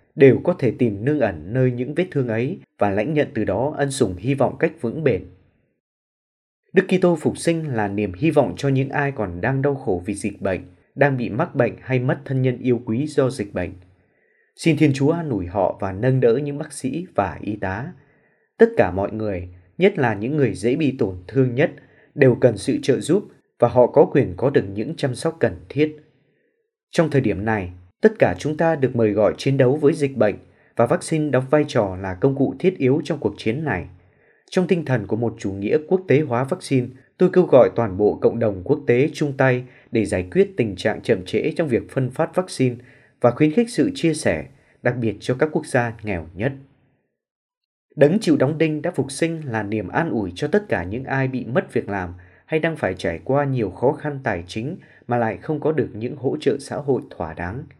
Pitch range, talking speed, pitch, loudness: 110-150 Hz, 225 wpm, 130 Hz, -21 LUFS